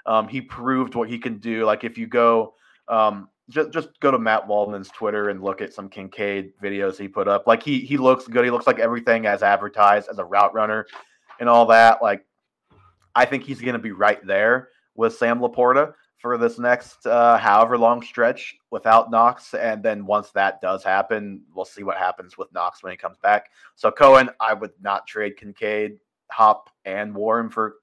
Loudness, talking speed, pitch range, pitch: -20 LUFS, 205 wpm, 105-120 Hz, 115 Hz